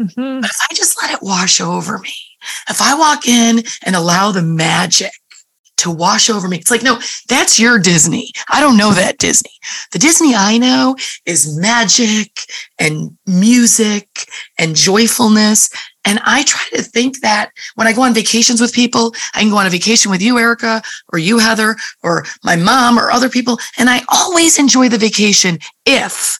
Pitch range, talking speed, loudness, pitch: 200-245 Hz, 180 wpm, -11 LUFS, 225 Hz